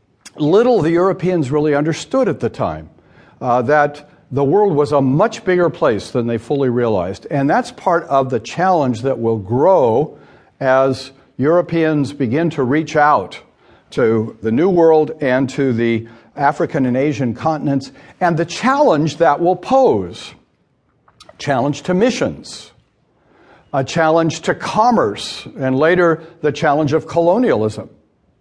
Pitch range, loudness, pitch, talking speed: 130-170 Hz, -16 LUFS, 150 Hz, 140 wpm